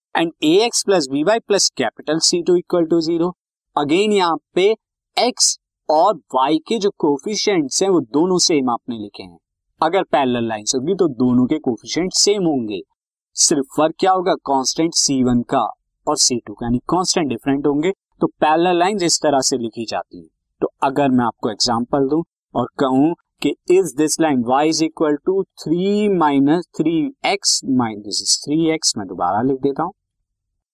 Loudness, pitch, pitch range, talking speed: -18 LUFS, 155 Hz, 125-185 Hz, 170 wpm